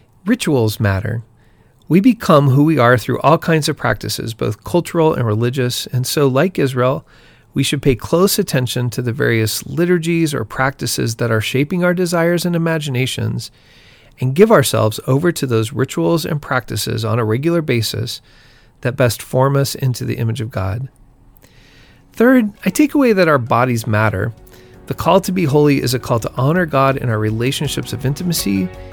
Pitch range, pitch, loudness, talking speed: 115-160 Hz, 130 Hz, -16 LUFS, 175 wpm